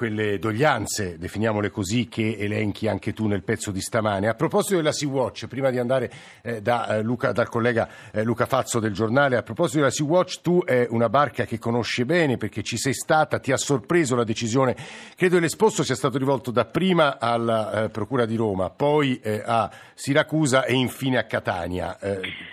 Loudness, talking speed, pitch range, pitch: -23 LUFS, 175 wpm, 110-140 Hz, 120 Hz